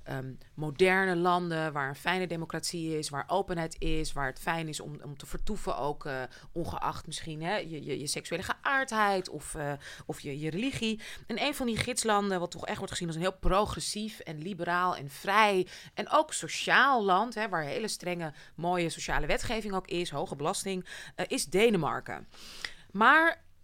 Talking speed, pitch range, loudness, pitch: 185 wpm, 155-200 Hz, -30 LUFS, 175 Hz